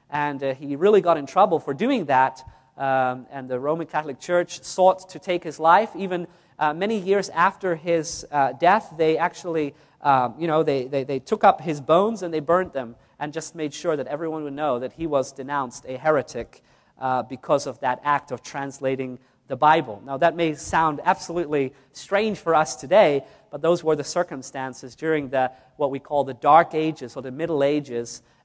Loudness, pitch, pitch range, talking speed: -23 LUFS, 150 Hz, 135-170 Hz, 200 wpm